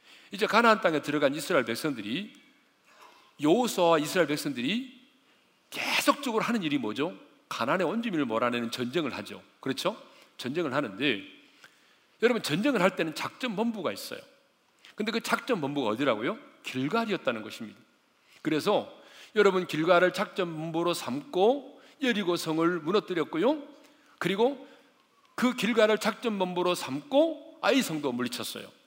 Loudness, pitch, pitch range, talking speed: -28 LUFS, 220 Hz, 175-265 Hz, 325 characters per minute